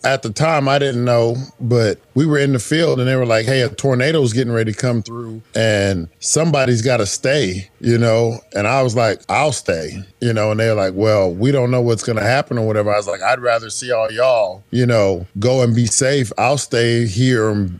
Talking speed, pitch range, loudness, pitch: 240 wpm, 110-130 Hz, -16 LUFS, 115 Hz